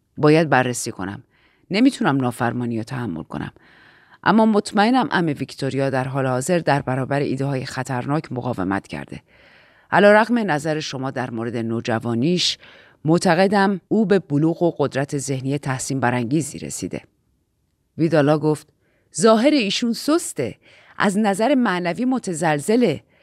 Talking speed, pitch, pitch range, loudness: 120 wpm, 145 Hz, 125-190 Hz, -20 LUFS